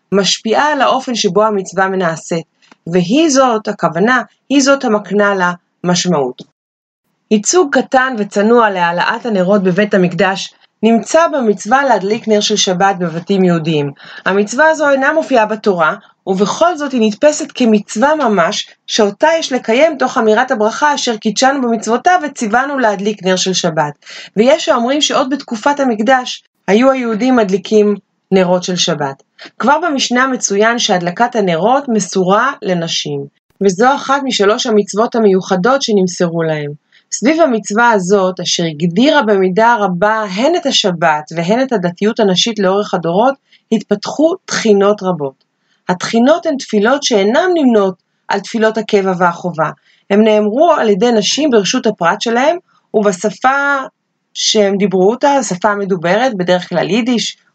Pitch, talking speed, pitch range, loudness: 215 Hz, 130 wpm, 190-255 Hz, -13 LUFS